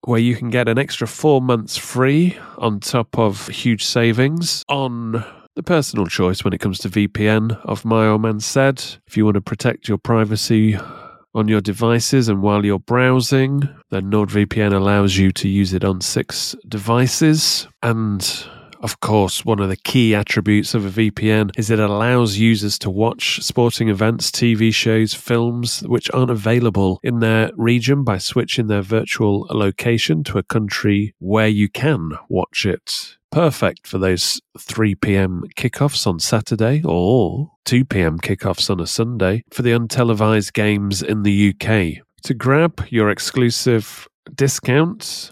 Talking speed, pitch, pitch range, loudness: 155 wpm, 110 Hz, 105-120 Hz, -18 LUFS